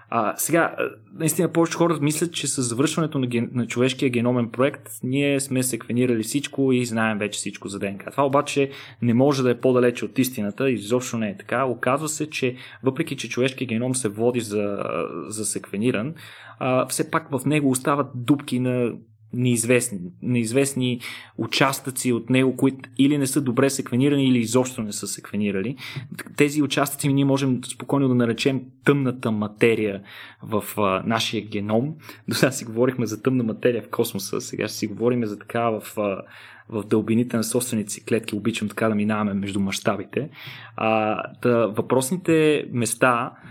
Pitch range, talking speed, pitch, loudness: 110-135 Hz, 165 wpm, 125 Hz, -23 LUFS